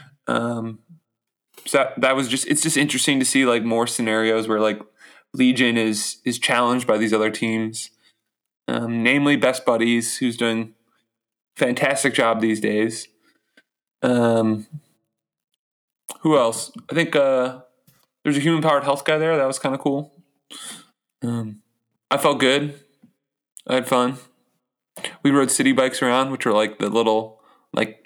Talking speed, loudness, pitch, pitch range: 150 wpm, -20 LUFS, 125 Hz, 115-140 Hz